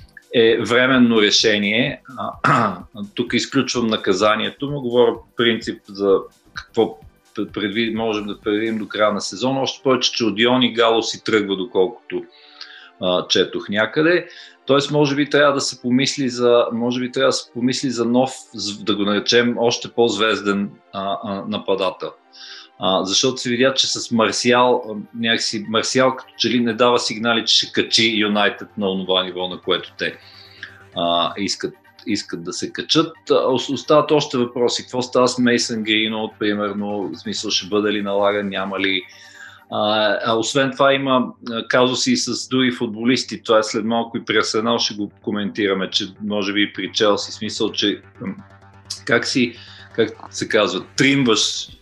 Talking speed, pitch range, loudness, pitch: 155 wpm, 105-125 Hz, -19 LUFS, 115 Hz